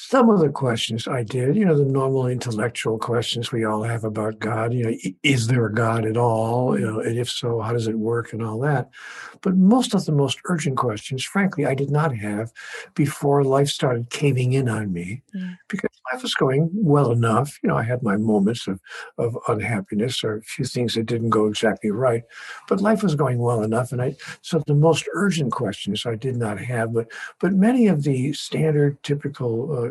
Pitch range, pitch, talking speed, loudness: 115-145 Hz, 125 Hz, 210 wpm, -22 LUFS